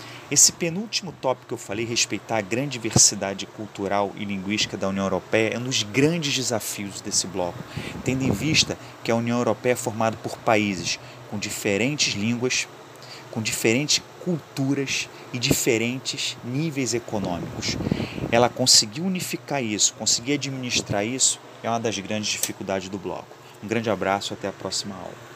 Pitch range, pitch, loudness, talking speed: 105-130 Hz, 115 Hz, -23 LUFS, 155 wpm